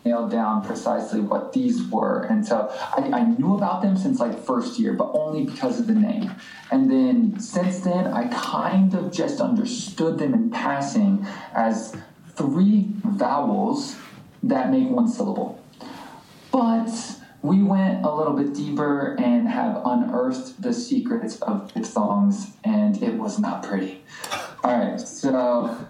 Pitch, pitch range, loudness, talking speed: 220 Hz, 190-245 Hz, -23 LUFS, 150 wpm